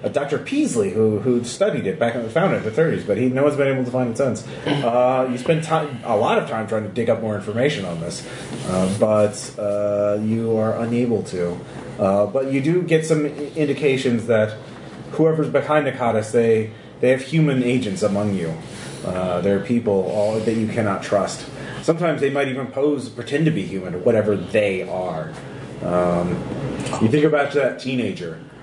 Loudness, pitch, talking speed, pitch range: -21 LUFS, 120 Hz, 195 wpm, 105-140 Hz